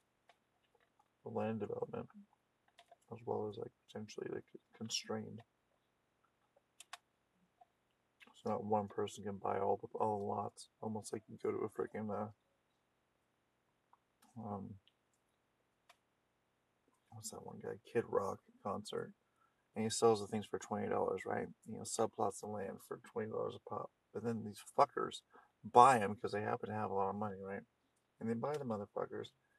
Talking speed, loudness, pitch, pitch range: 150 wpm, -40 LUFS, 105 Hz, 100-115 Hz